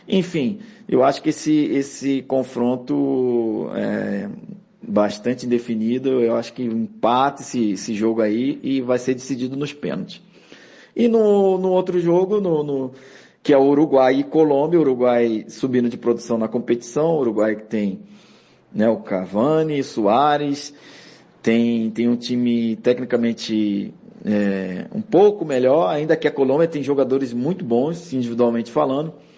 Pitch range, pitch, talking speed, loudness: 115-155 Hz, 130 Hz, 145 wpm, -20 LUFS